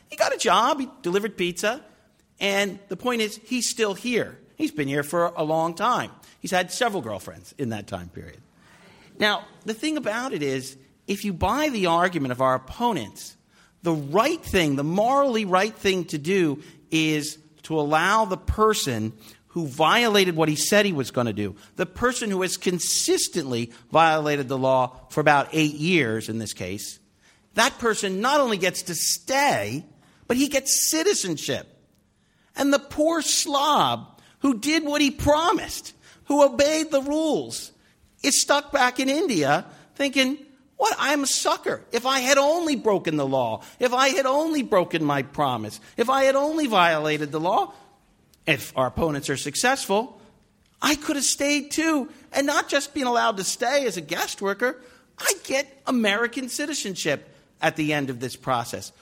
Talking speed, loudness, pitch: 170 wpm, -23 LUFS, 205 Hz